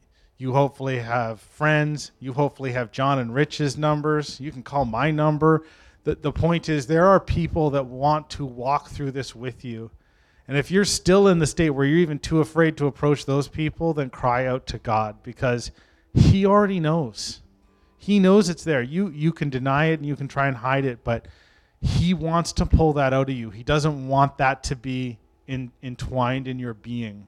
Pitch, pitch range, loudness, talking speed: 140 Hz, 125-155 Hz, -22 LUFS, 200 wpm